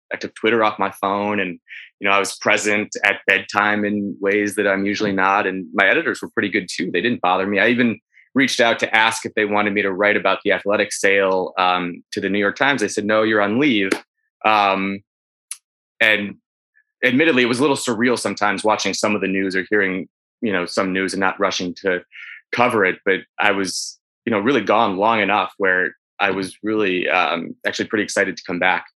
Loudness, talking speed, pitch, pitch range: -18 LUFS, 220 wpm, 100 Hz, 95-105 Hz